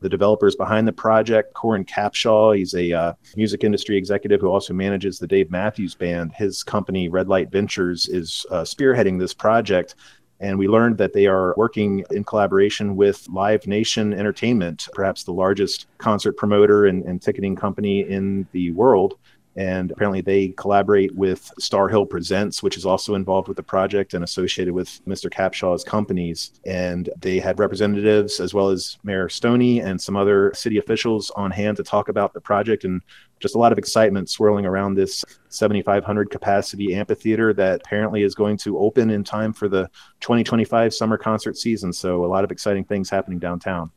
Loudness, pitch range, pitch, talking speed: -20 LUFS, 95-105 Hz, 100 Hz, 180 wpm